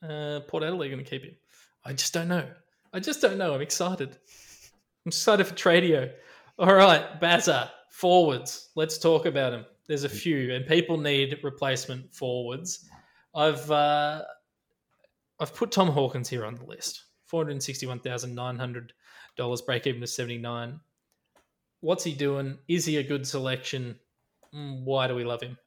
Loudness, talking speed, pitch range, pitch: -26 LUFS, 170 wpm, 130-170 Hz, 145 Hz